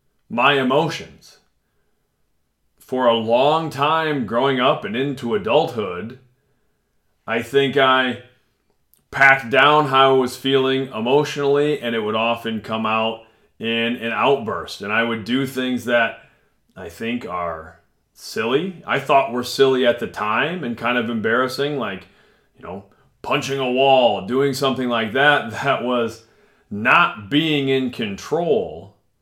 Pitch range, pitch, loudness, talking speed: 115-135 Hz, 125 Hz, -19 LUFS, 140 wpm